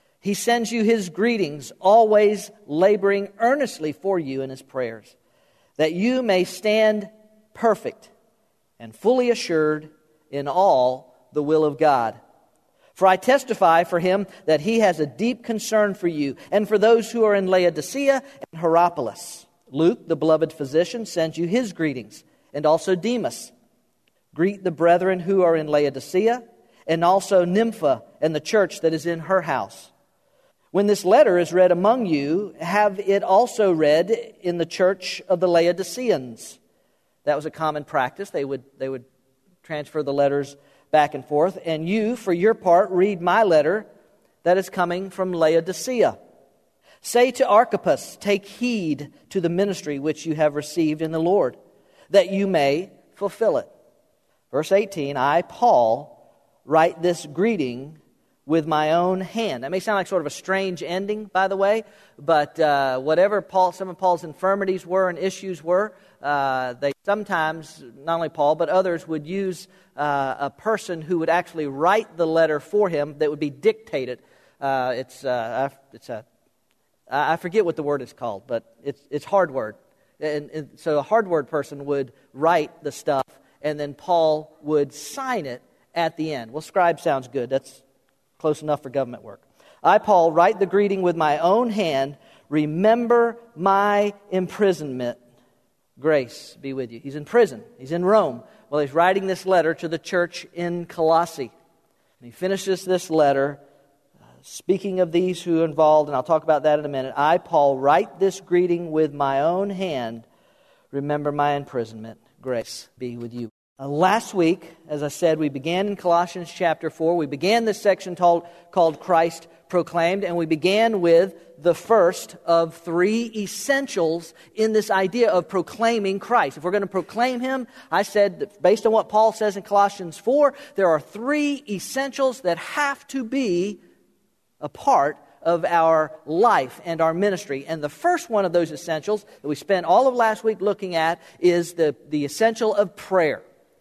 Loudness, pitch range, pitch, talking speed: -22 LUFS, 150-200 Hz, 175 Hz, 170 wpm